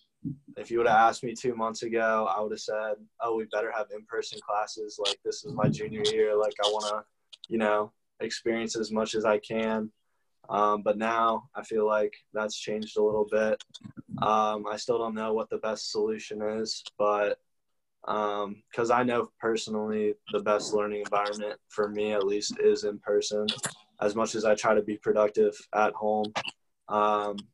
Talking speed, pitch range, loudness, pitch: 190 wpm, 105-115 Hz, -29 LUFS, 110 Hz